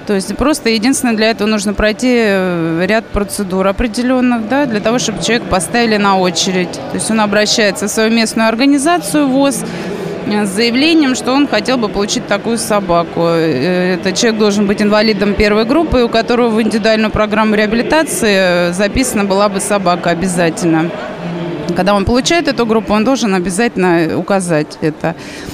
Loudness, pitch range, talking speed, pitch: -13 LUFS, 190-235 Hz, 155 wpm, 210 Hz